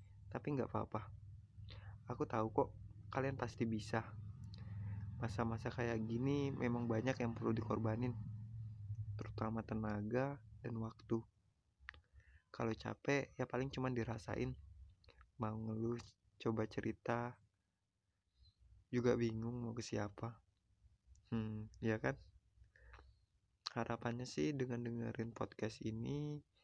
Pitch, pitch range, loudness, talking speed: 110 Hz, 105-120 Hz, -43 LUFS, 100 wpm